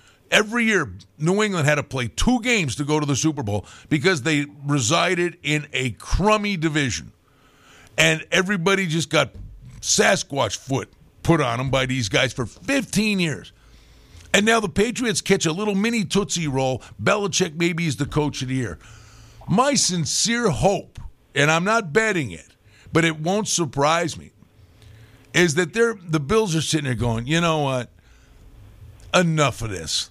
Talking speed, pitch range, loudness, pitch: 165 wpm, 125-190 Hz, -21 LUFS, 155 Hz